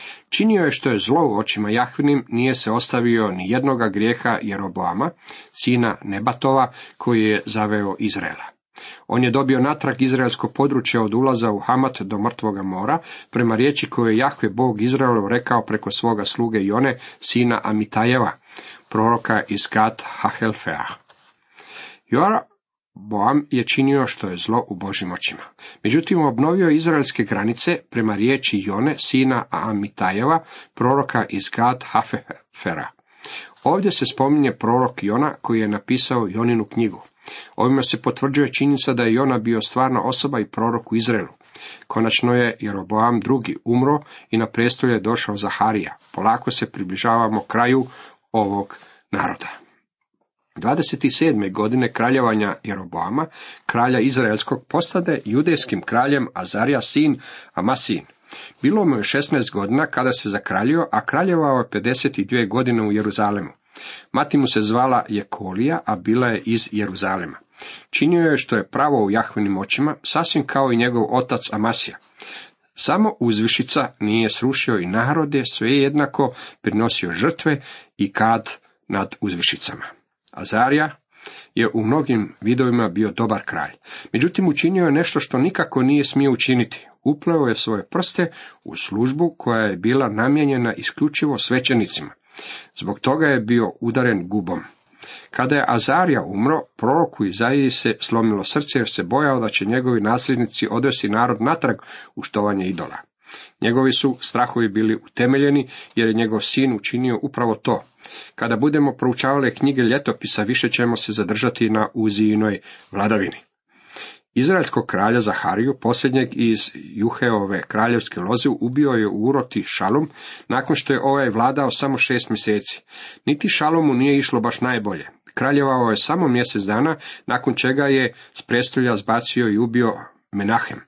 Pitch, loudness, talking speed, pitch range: 120 Hz, -20 LUFS, 140 wpm, 110-135 Hz